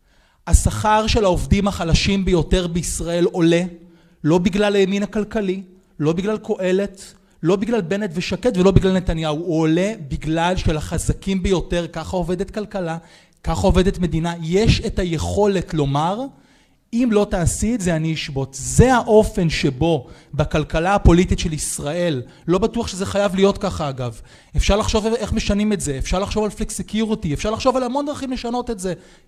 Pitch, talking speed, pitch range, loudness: 185 Hz, 155 wpm, 165-205 Hz, -20 LUFS